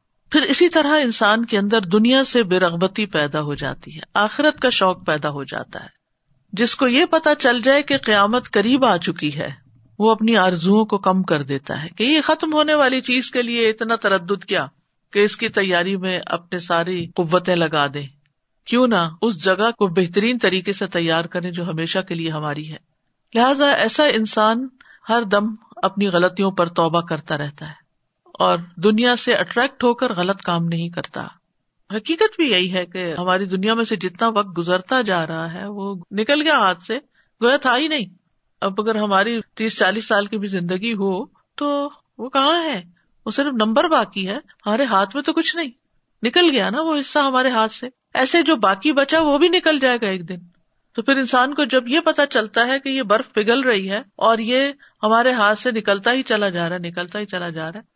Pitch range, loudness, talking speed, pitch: 180-255 Hz, -18 LUFS, 205 wpm, 210 Hz